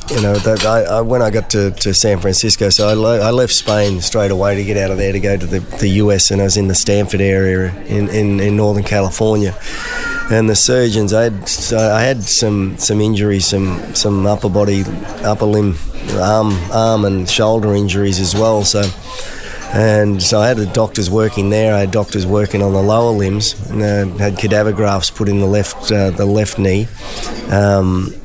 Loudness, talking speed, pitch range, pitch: -14 LUFS, 210 wpm, 100-110 Hz, 105 Hz